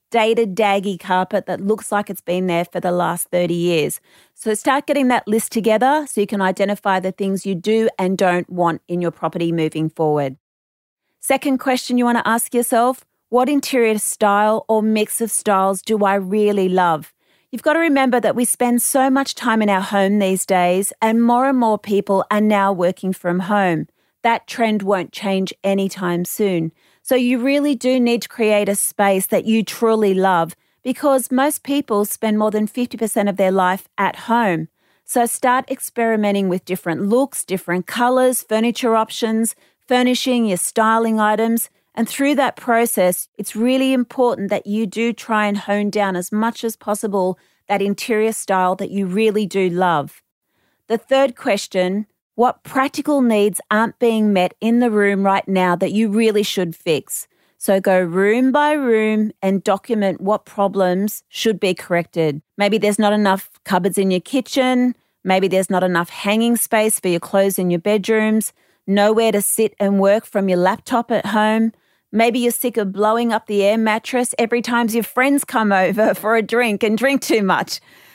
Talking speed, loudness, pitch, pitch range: 180 wpm, -18 LUFS, 215 Hz, 190-235 Hz